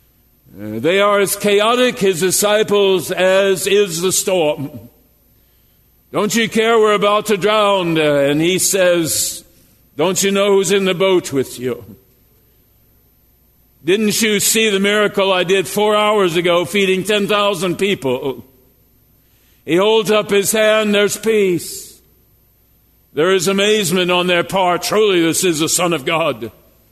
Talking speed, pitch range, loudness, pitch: 140 wpm, 165-205 Hz, -14 LUFS, 190 Hz